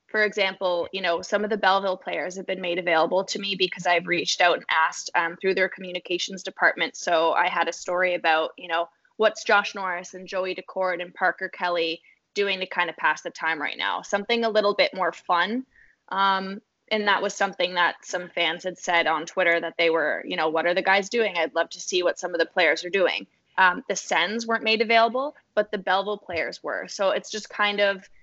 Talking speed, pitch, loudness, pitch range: 225 wpm, 185 Hz, -24 LUFS, 175-200 Hz